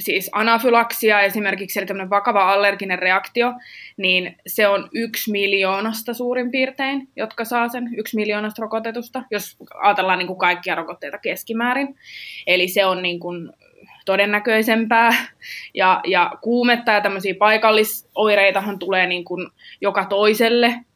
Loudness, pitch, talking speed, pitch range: -18 LUFS, 210 Hz, 125 wpm, 195-230 Hz